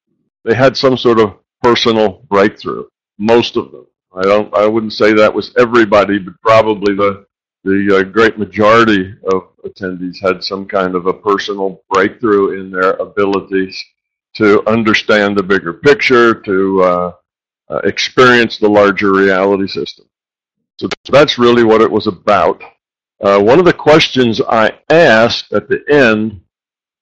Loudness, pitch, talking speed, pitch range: -11 LUFS, 100 Hz, 150 wpm, 95-115 Hz